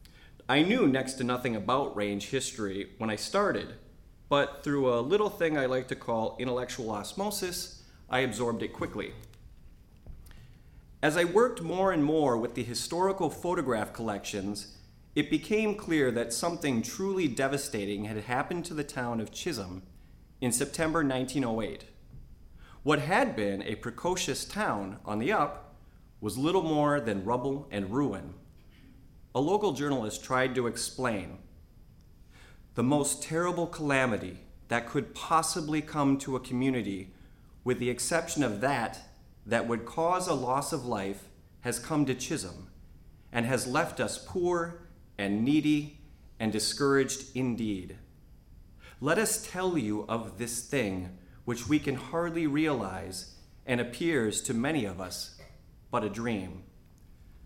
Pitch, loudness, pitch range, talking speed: 125 Hz, -30 LUFS, 105-150 Hz, 140 wpm